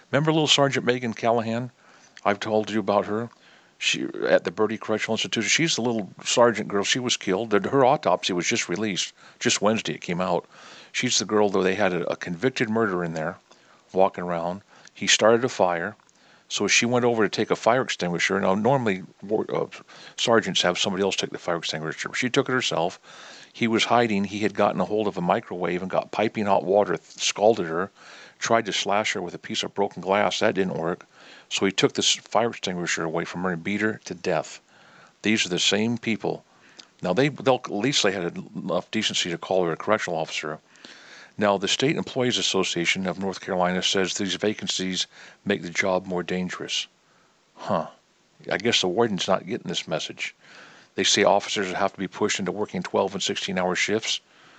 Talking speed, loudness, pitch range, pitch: 200 wpm, -24 LUFS, 90-115 Hz, 105 Hz